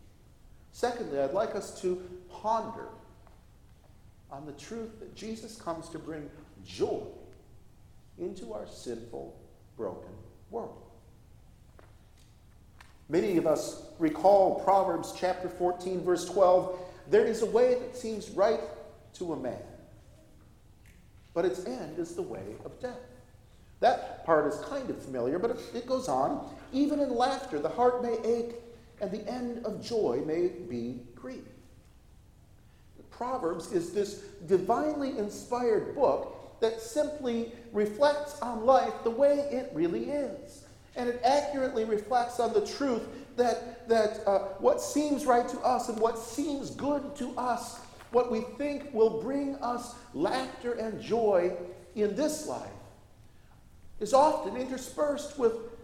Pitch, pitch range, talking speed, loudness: 225 Hz, 180-255 Hz, 135 wpm, -30 LUFS